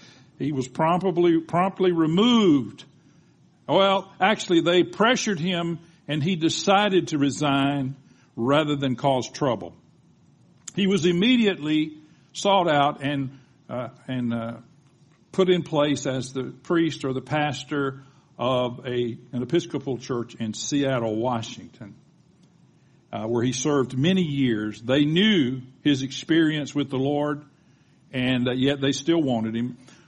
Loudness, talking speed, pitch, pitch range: -23 LUFS, 130 wpm, 145 Hz, 130-170 Hz